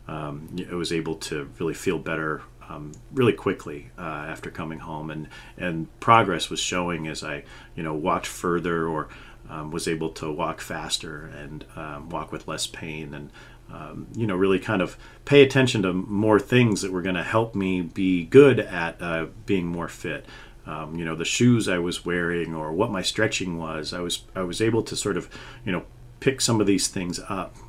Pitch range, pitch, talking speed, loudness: 80-105 Hz, 90 Hz, 200 wpm, -24 LUFS